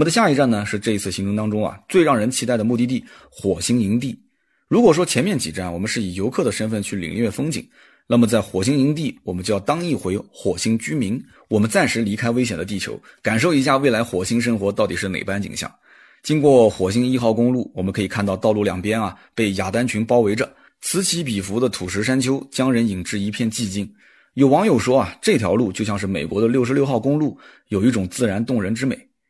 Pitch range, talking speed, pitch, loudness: 100-130 Hz, 345 characters per minute, 115 Hz, -20 LUFS